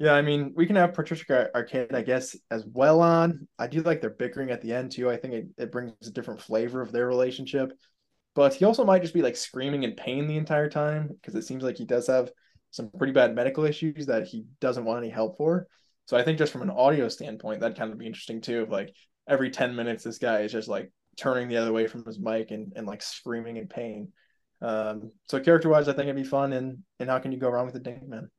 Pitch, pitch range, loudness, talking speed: 130 Hz, 115-150 Hz, -27 LUFS, 255 wpm